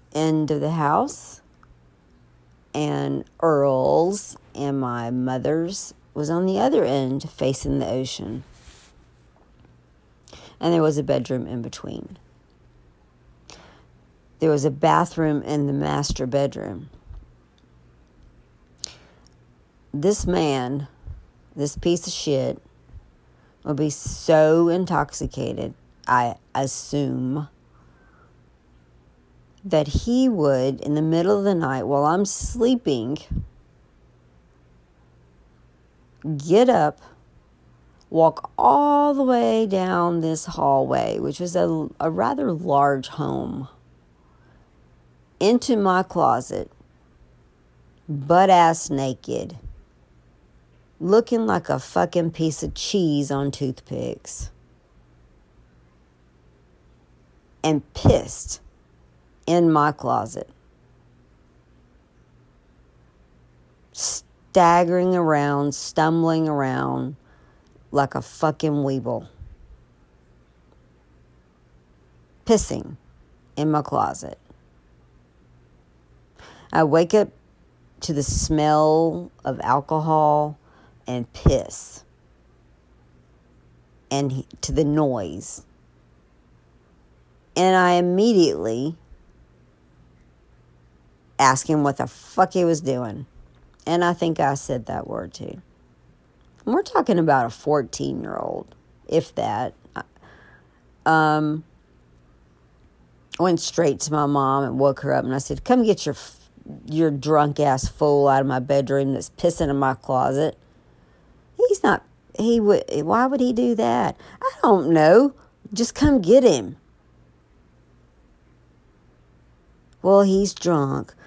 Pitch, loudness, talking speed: 125 Hz, -21 LUFS, 95 wpm